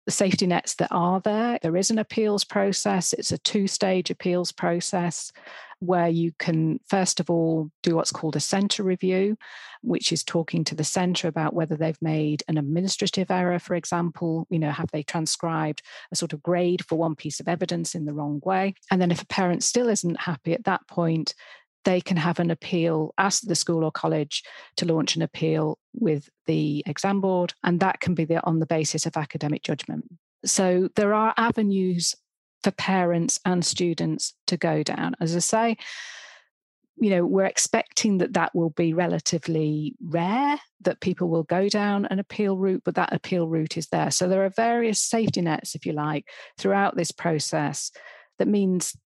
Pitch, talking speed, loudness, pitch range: 175 Hz, 190 wpm, -25 LUFS, 165-195 Hz